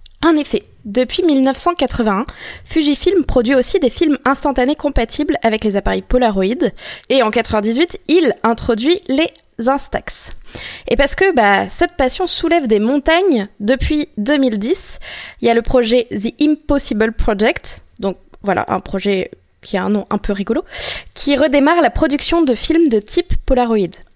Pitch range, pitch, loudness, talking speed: 225-315 Hz, 265 Hz, -15 LUFS, 150 wpm